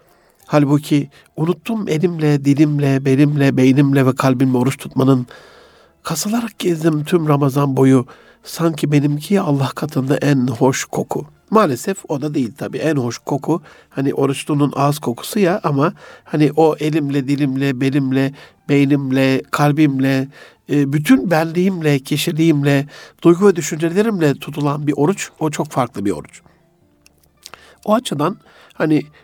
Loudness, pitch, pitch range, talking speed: -17 LUFS, 145 Hz, 135-160 Hz, 125 wpm